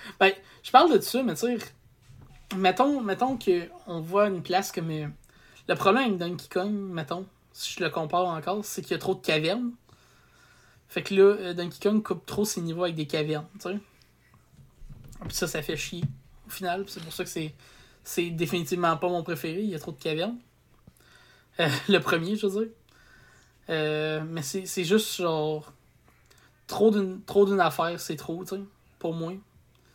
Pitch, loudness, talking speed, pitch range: 180 Hz, -27 LUFS, 190 wpm, 160-195 Hz